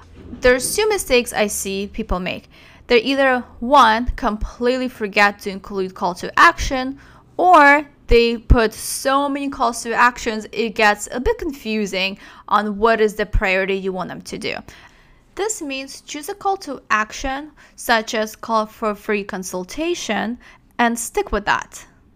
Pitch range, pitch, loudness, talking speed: 210-275 Hz, 230 Hz, -18 LUFS, 155 wpm